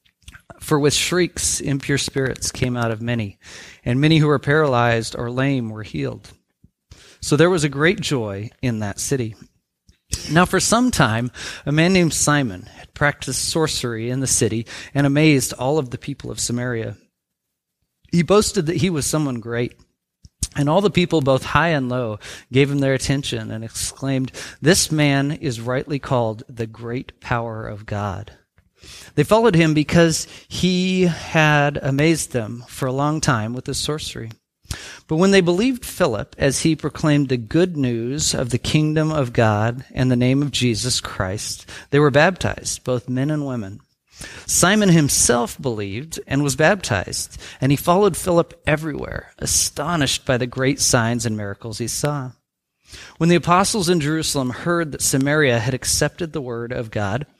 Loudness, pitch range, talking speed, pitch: -19 LUFS, 120-155 Hz, 165 wpm, 135 Hz